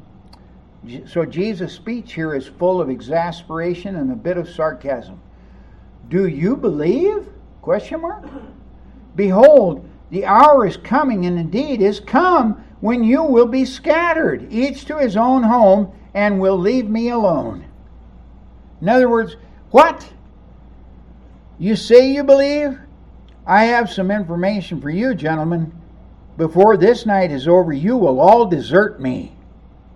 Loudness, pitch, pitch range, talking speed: -16 LUFS, 200 Hz, 165-250 Hz, 135 wpm